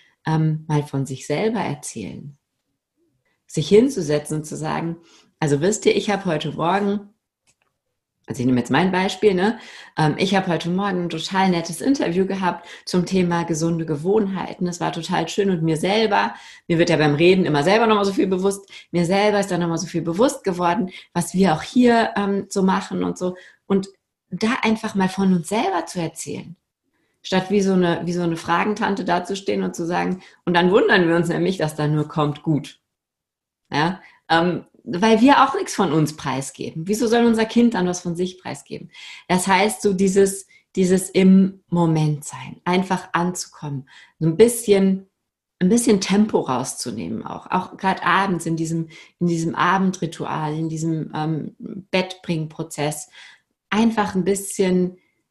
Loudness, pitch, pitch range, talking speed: -20 LUFS, 180 Hz, 165-200 Hz, 170 wpm